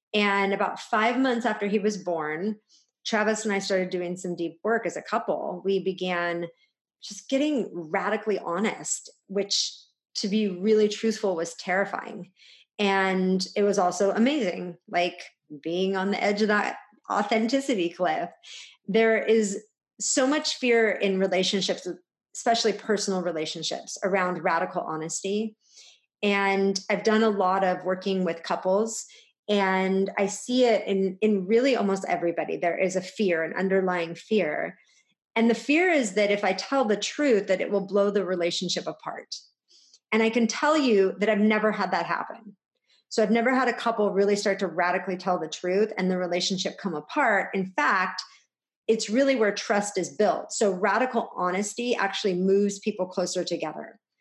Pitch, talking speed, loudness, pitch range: 200 Hz, 160 wpm, -25 LUFS, 185-220 Hz